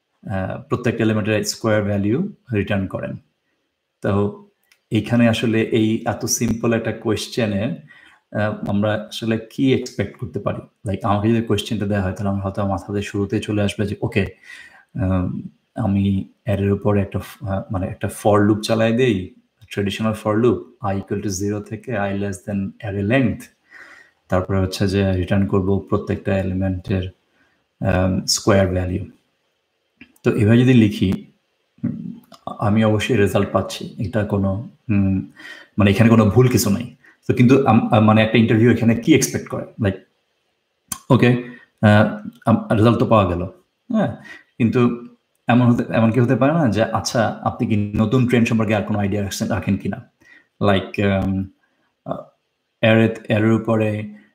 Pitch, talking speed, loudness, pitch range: 105 Hz, 115 wpm, -19 LUFS, 100-115 Hz